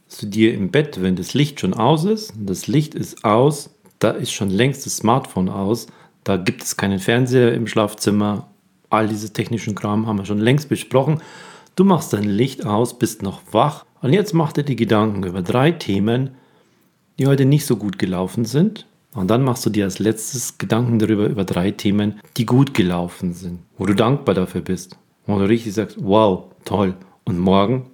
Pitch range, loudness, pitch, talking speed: 100-130 Hz, -19 LUFS, 110 Hz, 200 wpm